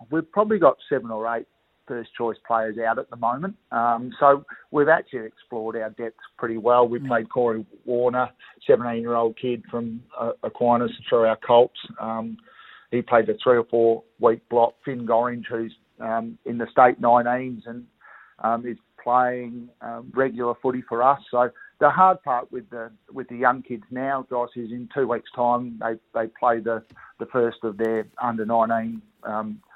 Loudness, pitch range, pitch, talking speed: -23 LUFS, 115-125 Hz, 120 Hz, 175 wpm